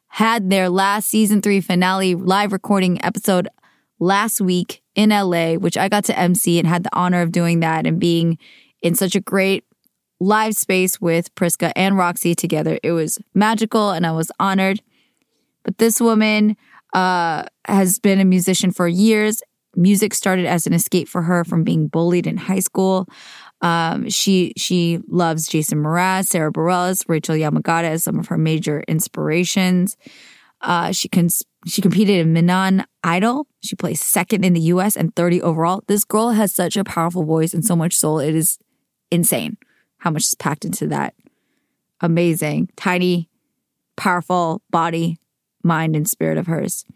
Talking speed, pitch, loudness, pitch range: 165 wpm, 180 Hz, -18 LUFS, 170-200 Hz